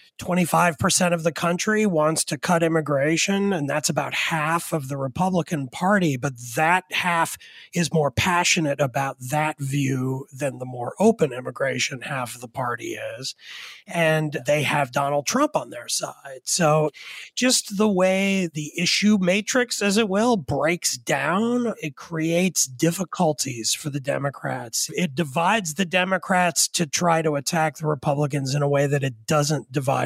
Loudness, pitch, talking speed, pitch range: -22 LUFS, 160 Hz, 155 wpm, 145-185 Hz